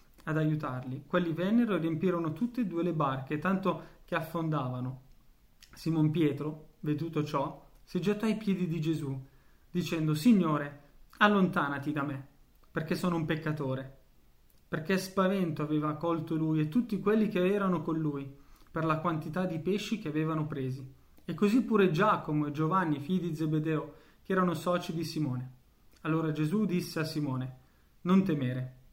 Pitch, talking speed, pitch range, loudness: 160 Hz, 155 wpm, 145-180 Hz, -31 LUFS